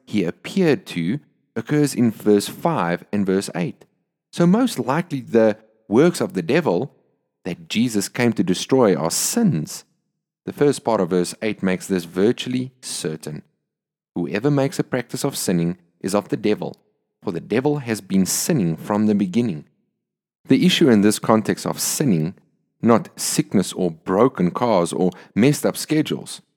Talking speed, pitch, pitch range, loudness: 160 wpm, 115 Hz, 100-145 Hz, -20 LUFS